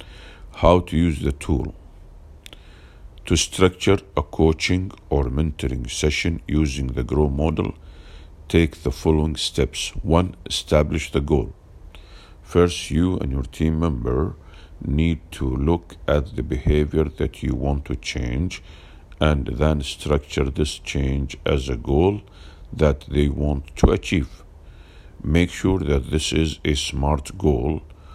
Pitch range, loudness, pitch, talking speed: 70-80 Hz, -22 LUFS, 75 Hz, 130 wpm